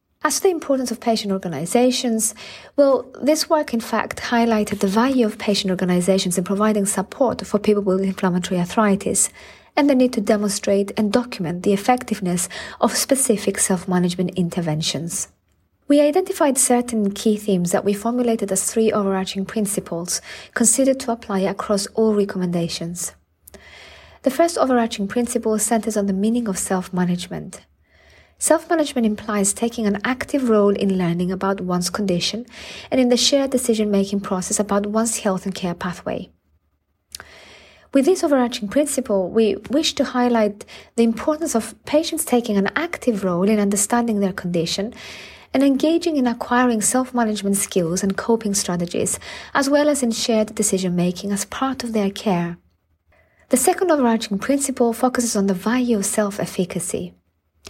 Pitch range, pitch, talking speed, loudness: 190-245 Hz, 215 Hz, 145 wpm, -20 LUFS